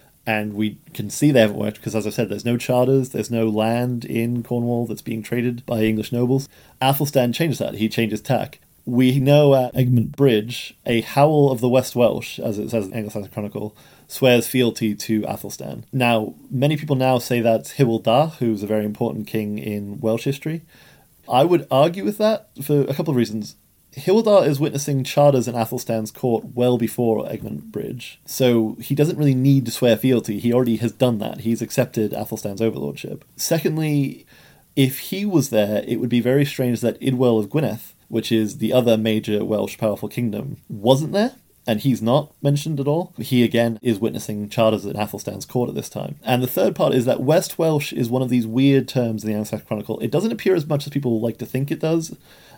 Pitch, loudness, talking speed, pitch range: 120 Hz, -20 LUFS, 200 wpm, 110-135 Hz